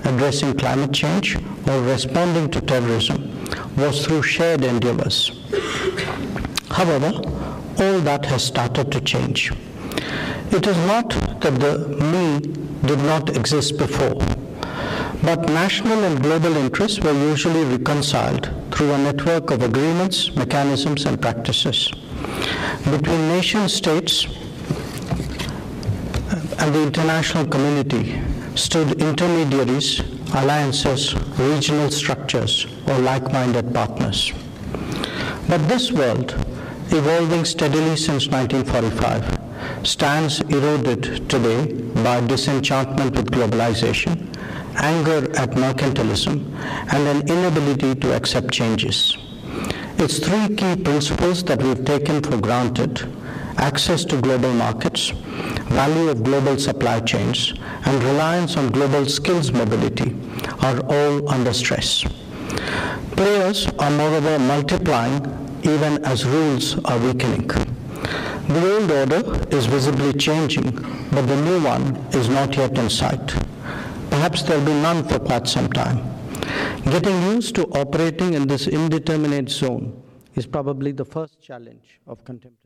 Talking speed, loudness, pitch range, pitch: 115 wpm, -20 LUFS, 130-155 Hz, 140 Hz